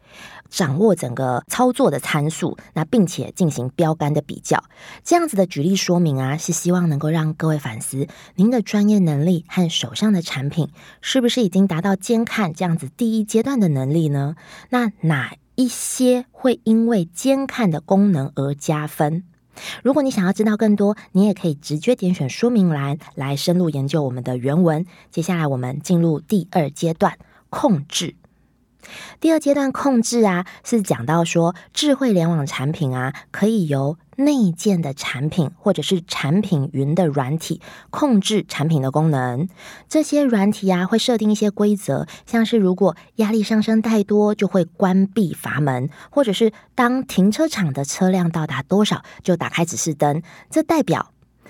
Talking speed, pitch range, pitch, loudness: 255 characters per minute, 155-215 Hz, 180 Hz, -19 LUFS